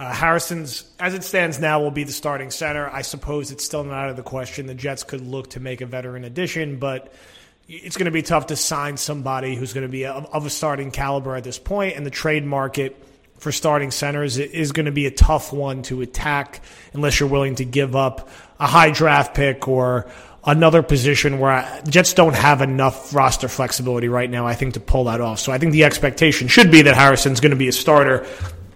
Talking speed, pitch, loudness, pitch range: 225 wpm, 140 Hz, -18 LUFS, 130-150 Hz